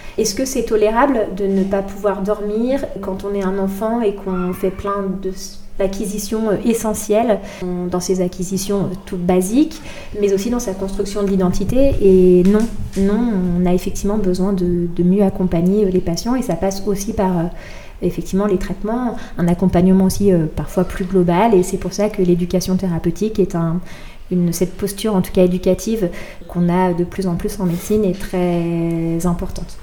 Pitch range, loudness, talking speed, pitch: 180-205 Hz, -18 LUFS, 175 wpm, 190 Hz